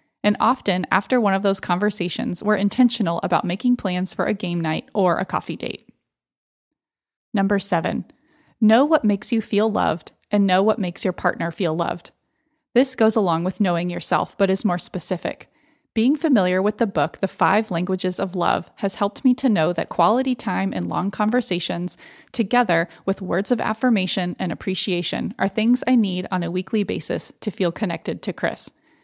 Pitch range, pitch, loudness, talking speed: 180-230 Hz, 195 Hz, -21 LUFS, 180 wpm